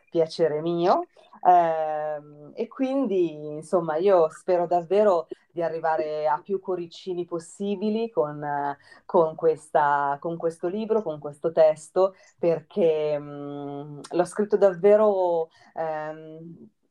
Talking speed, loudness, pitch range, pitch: 95 wpm, -25 LUFS, 155-185 Hz, 165 Hz